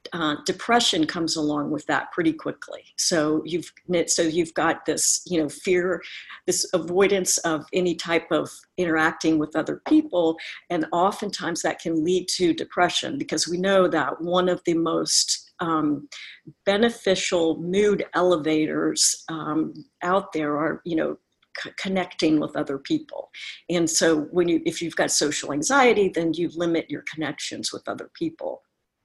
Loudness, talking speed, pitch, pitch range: -23 LUFS, 155 wpm, 170 Hz, 160-185 Hz